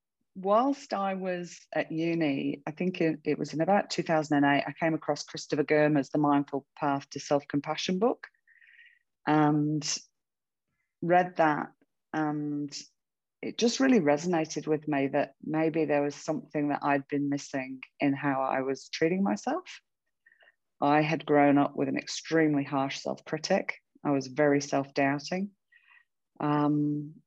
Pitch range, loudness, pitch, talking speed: 145-180 Hz, -29 LUFS, 150 Hz, 145 wpm